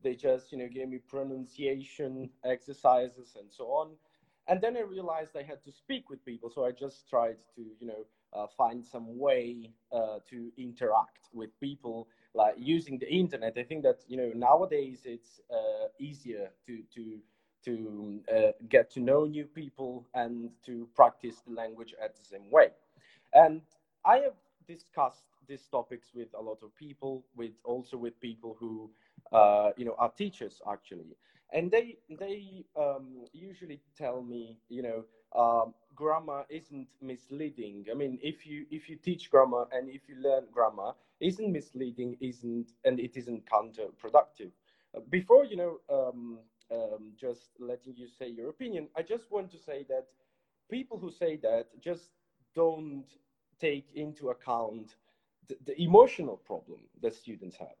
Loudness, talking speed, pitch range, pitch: -31 LUFS, 160 wpm, 120-155 Hz, 130 Hz